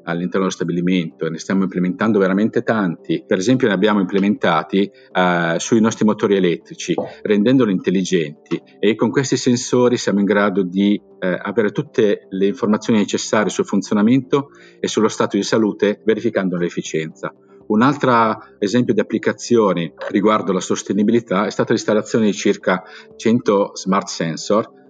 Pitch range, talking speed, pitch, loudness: 90-115 Hz, 145 wpm, 100 Hz, -18 LUFS